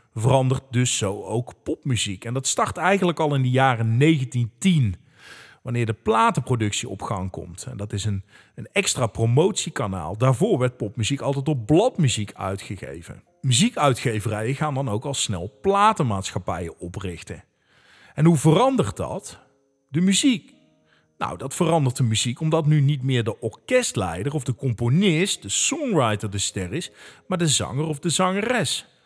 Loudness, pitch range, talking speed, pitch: -22 LUFS, 105-155 Hz, 150 wpm, 130 Hz